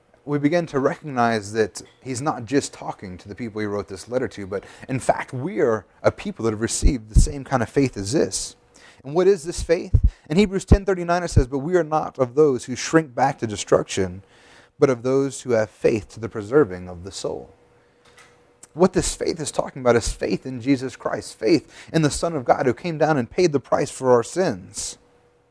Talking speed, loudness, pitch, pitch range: 220 wpm, -22 LUFS, 130 Hz, 105-155 Hz